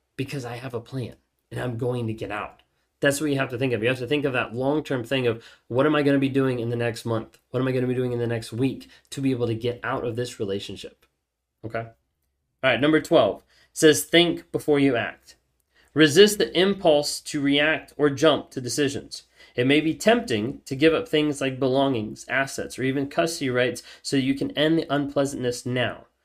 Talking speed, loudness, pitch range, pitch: 230 wpm, -23 LUFS, 120-145 Hz, 135 Hz